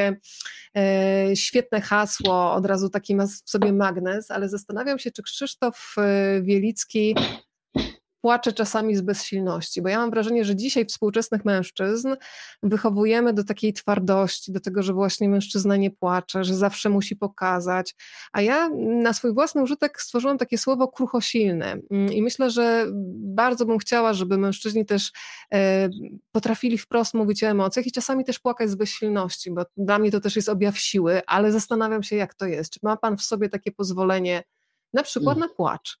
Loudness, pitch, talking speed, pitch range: -23 LUFS, 210 Hz, 165 wpm, 195-230 Hz